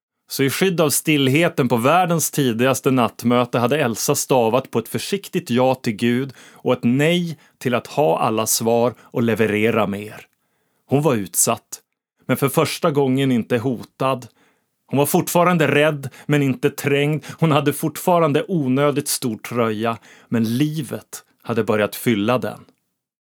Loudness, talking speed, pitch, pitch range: -19 LUFS, 145 wpm, 135 Hz, 120-150 Hz